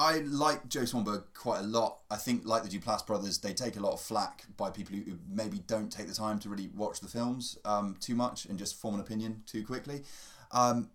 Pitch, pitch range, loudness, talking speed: 110 Hz, 100-125 Hz, -34 LUFS, 235 wpm